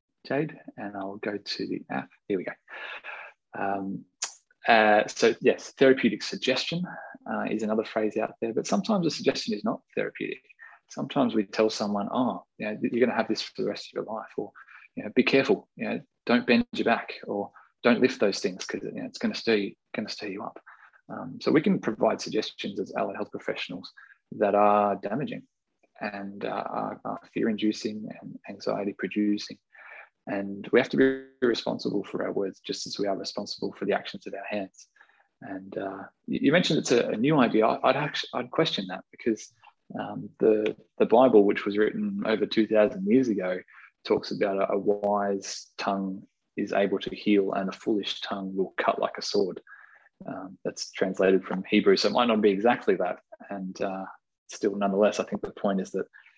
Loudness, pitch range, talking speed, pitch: -27 LUFS, 100-130 Hz, 190 wpm, 105 Hz